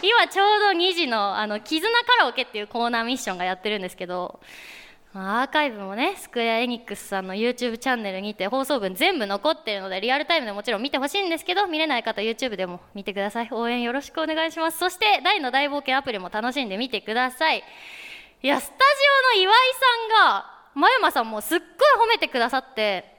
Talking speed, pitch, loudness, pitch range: 475 characters per minute, 260 Hz, -22 LUFS, 215-335 Hz